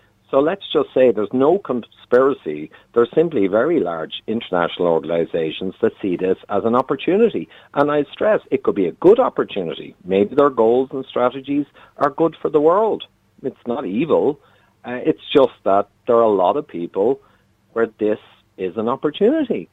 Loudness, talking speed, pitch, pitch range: -19 LUFS, 175 wpm, 120 Hz, 100-145 Hz